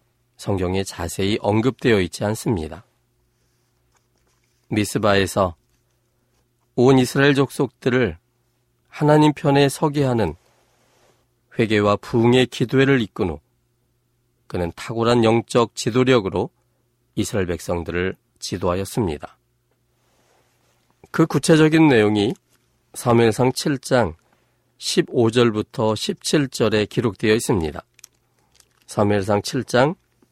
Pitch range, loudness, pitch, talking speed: 100-125 Hz, -20 LUFS, 120 Hz, 215 characters per minute